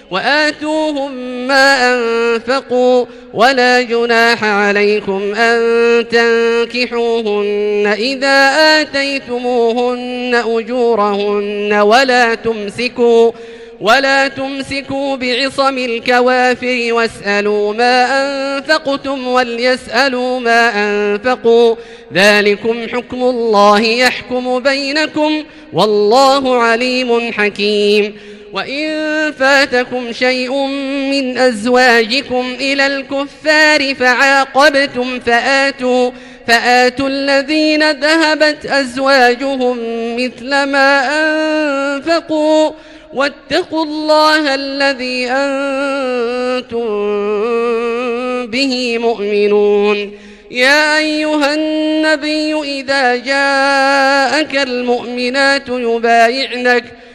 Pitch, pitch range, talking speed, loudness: 250 Hz, 235-275 Hz, 65 wpm, -12 LUFS